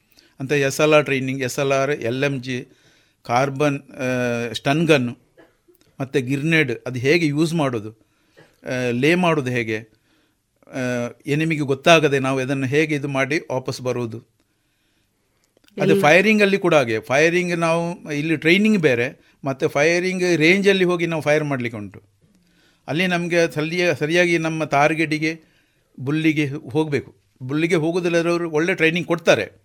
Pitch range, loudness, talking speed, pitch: 130-165 Hz, -19 LUFS, 125 wpm, 150 Hz